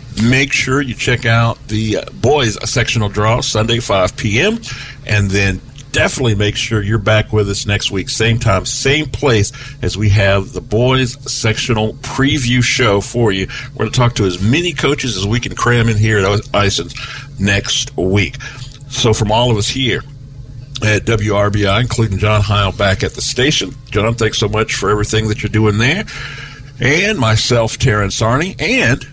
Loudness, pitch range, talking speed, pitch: -14 LUFS, 105-130 Hz, 175 wpm, 115 Hz